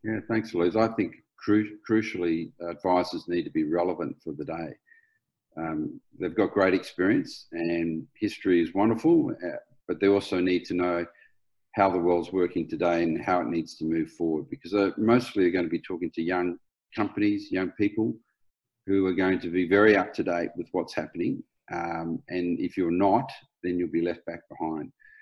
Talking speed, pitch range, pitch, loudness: 185 wpm, 85-110 Hz, 95 Hz, -27 LUFS